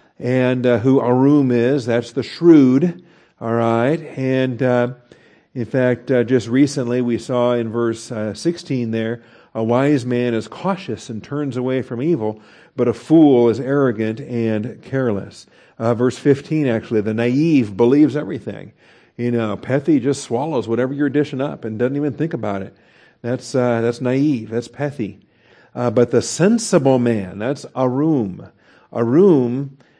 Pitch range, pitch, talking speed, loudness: 115-140 Hz, 125 Hz, 155 wpm, -18 LUFS